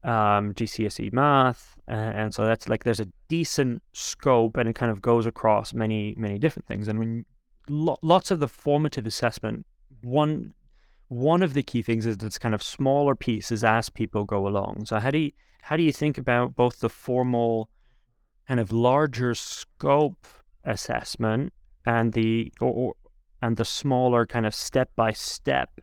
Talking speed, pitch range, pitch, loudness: 175 wpm, 110-135 Hz, 115 Hz, -25 LUFS